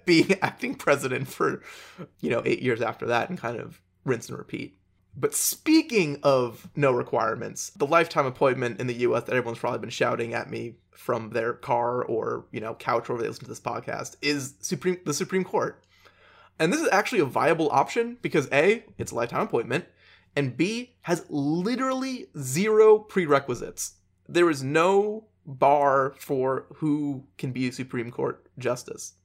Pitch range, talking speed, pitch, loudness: 125-190 Hz, 170 wpm, 145 Hz, -26 LUFS